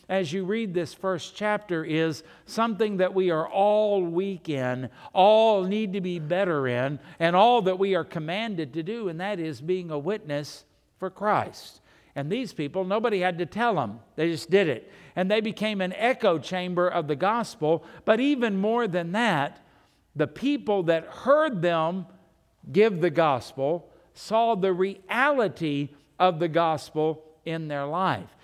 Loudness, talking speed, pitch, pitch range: -26 LUFS, 165 wpm, 180 Hz, 160-210 Hz